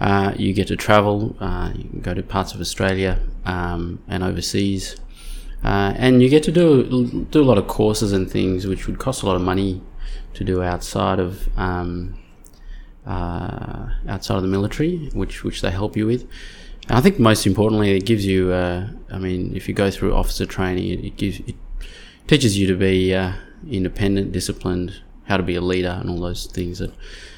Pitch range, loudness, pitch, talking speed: 90-105 Hz, -20 LUFS, 95 Hz, 195 wpm